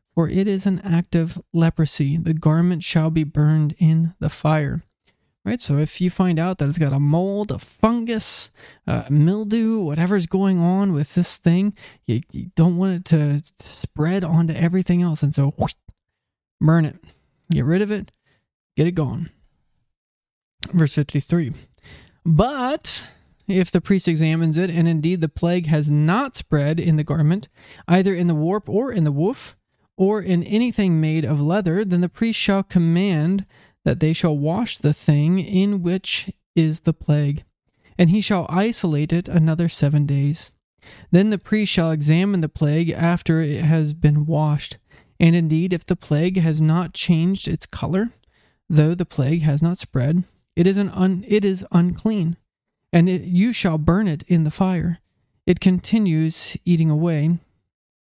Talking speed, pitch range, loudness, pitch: 165 wpm, 155-185 Hz, -20 LUFS, 170 Hz